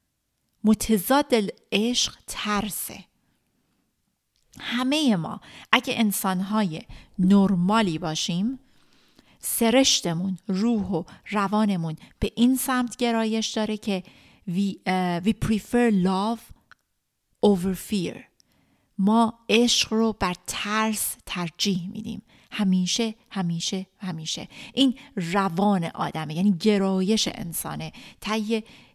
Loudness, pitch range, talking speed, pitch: -24 LUFS, 190-225 Hz, 90 wpm, 210 Hz